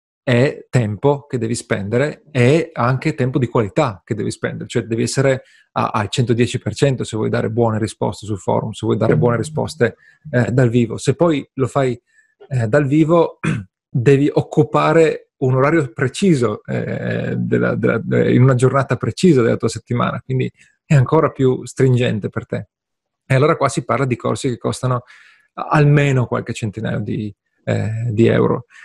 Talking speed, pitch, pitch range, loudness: 165 wpm, 125 Hz, 115-145 Hz, -17 LUFS